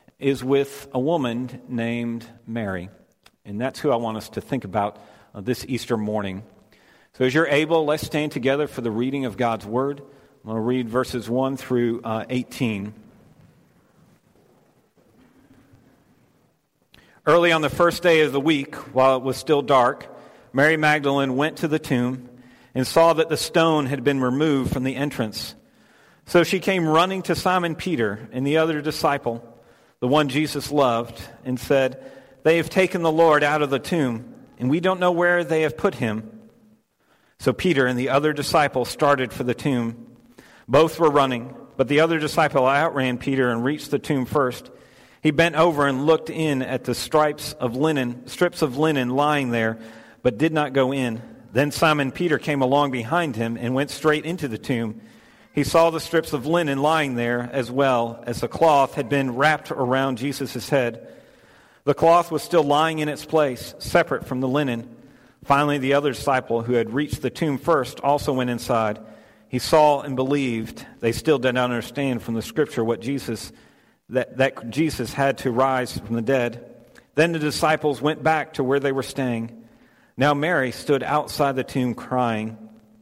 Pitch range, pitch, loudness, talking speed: 120-150 Hz, 135 Hz, -22 LUFS, 180 wpm